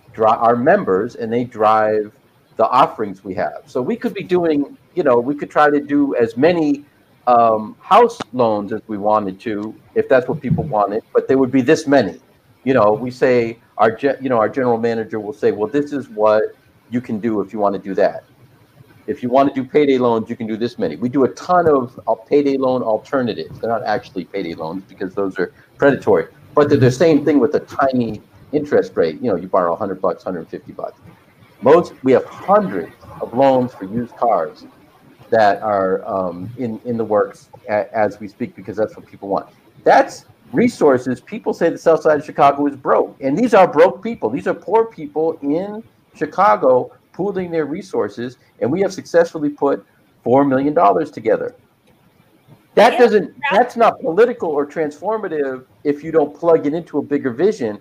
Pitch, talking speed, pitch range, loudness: 135 Hz, 195 wpm, 110-155 Hz, -17 LUFS